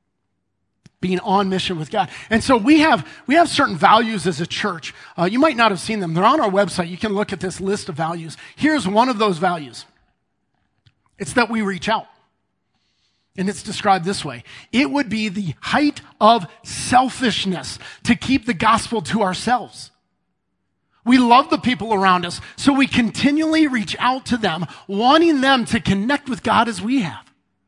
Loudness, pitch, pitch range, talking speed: -18 LUFS, 210 Hz, 175-245 Hz, 185 wpm